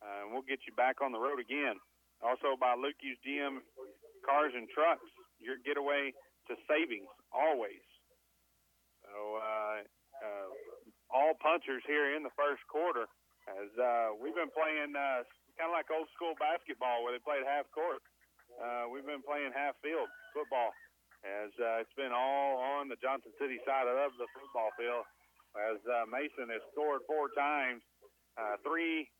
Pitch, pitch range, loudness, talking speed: 135 Hz, 120-150 Hz, -36 LUFS, 160 wpm